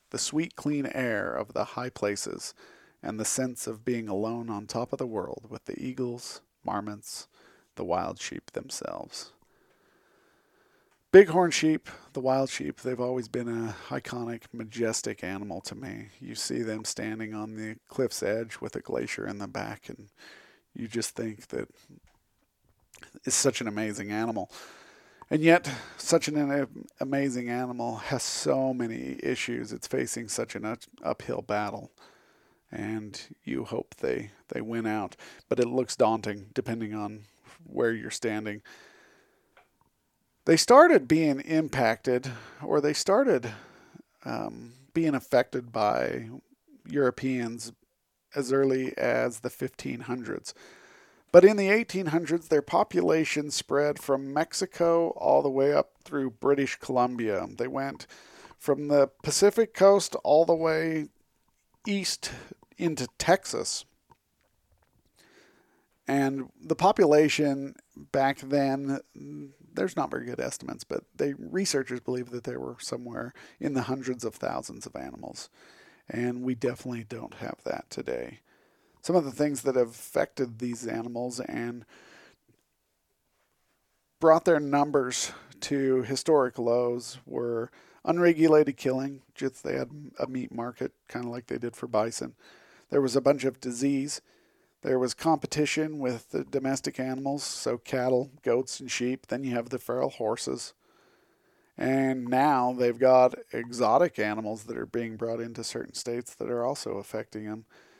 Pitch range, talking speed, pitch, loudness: 115-145 Hz, 140 wpm, 130 Hz, -28 LUFS